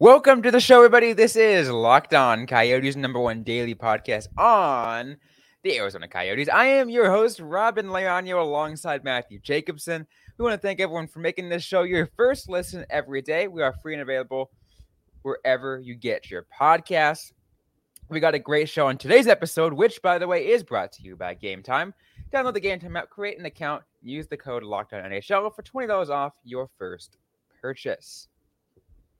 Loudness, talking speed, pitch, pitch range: -22 LUFS, 180 wpm, 160 Hz, 130-200 Hz